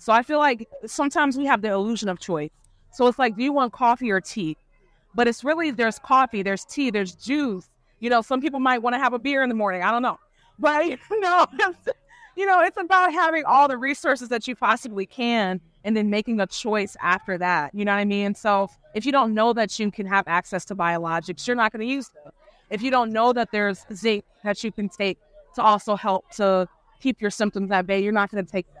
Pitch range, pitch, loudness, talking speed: 195-260 Hz, 220 Hz, -23 LUFS, 240 wpm